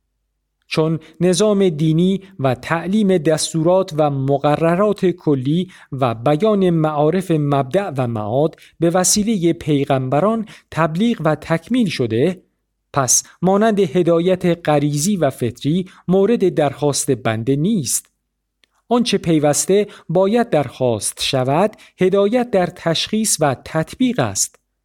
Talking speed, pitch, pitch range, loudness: 105 wpm, 165 Hz, 145-195 Hz, -17 LUFS